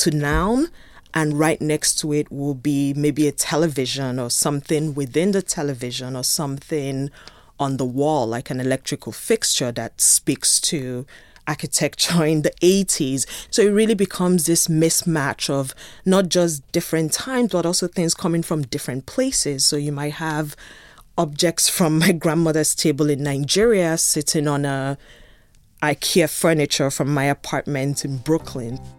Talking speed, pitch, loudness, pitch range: 150 wpm, 150 Hz, -20 LUFS, 140-165 Hz